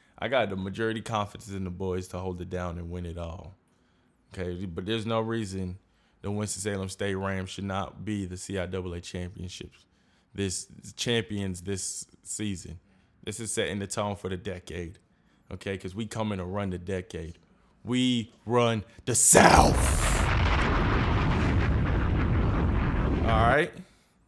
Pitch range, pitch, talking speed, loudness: 90-105 Hz, 95 Hz, 145 wpm, -28 LUFS